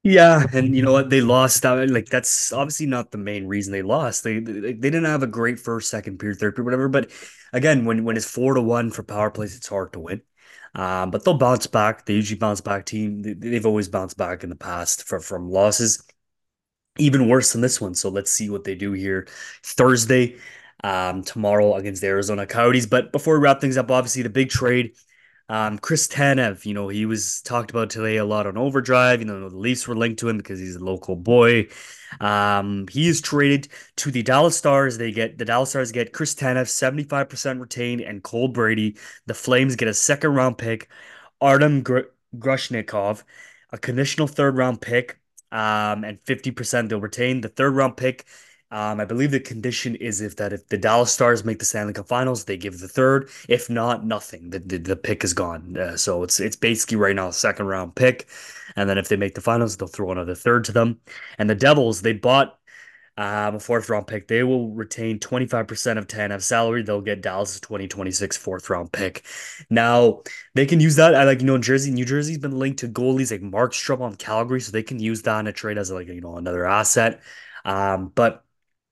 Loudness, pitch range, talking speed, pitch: -21 LUFS, 105-130 Hz, 215 wpm, 115 Hz